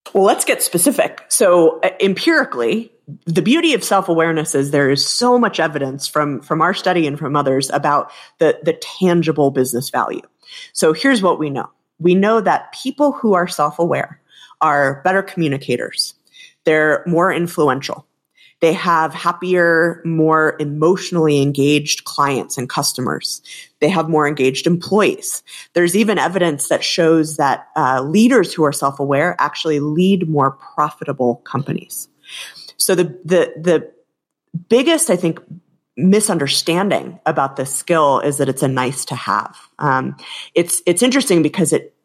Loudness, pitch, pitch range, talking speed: -16 LUFS, 165 Hz, 145-185 Hz, 145 wpm